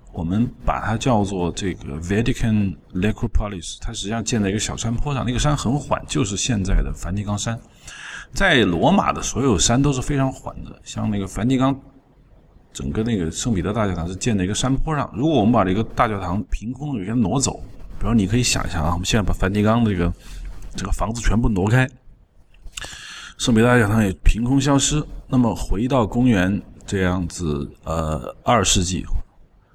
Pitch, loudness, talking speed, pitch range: 110 Hz, -21 LUFS, 315 characters per minute, 95-125 Hz